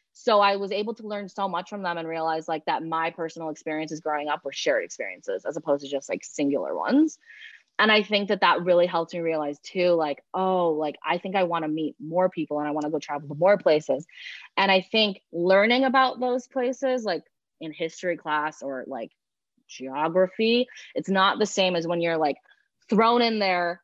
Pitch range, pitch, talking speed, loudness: 155-205 Hz, 175 Hz, 210 wpm, -25 LUFS